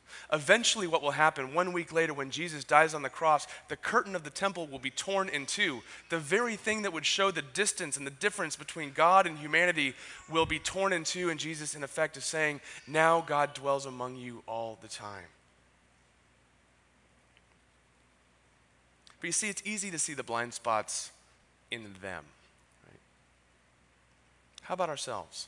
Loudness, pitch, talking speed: -30 LUFS, 145 Hz, 170 wpm